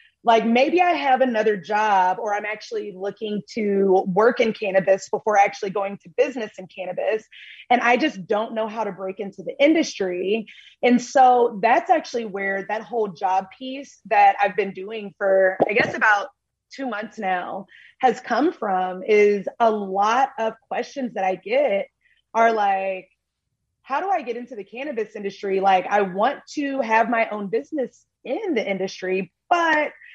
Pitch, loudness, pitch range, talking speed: 215 Hz, -21 LUFS, 195-245 Hz, 170 wpm